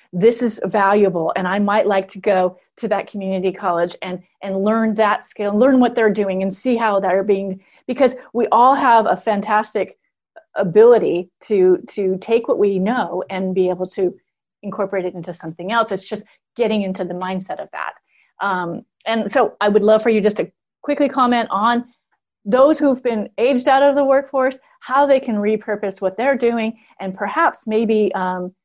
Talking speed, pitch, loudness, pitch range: 185 wpm, 210 Hz, -18 LUFS, 190-240 Hz